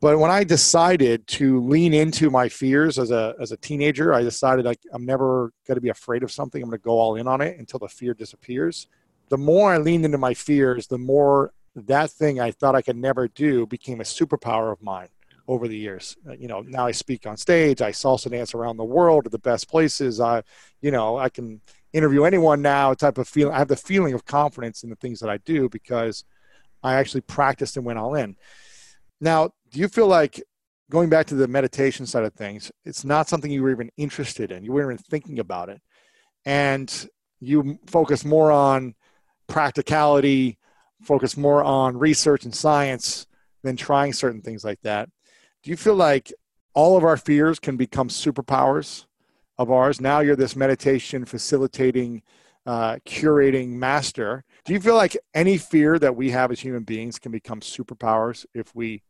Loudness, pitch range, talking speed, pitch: -21 LUFS, 120-150 Hz, 200 wpm, 135 Hz